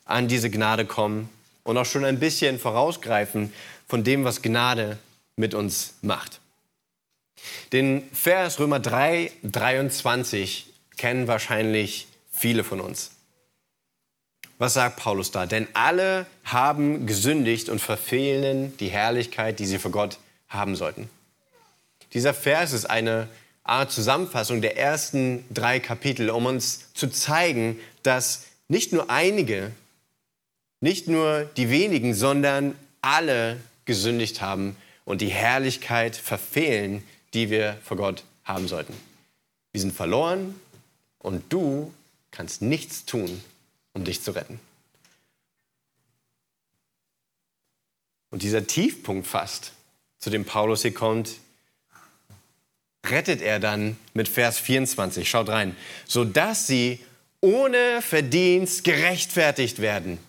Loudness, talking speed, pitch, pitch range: -24 LUFS, 115 wpm, 120 Hz, 110-140 Hz